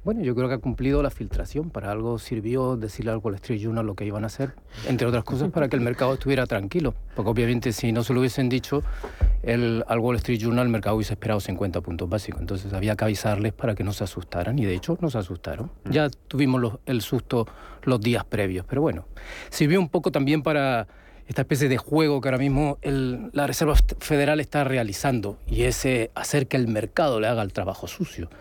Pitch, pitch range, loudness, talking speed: 120 Hz, 110-135 Hz, -25 LUFS, 220 wpm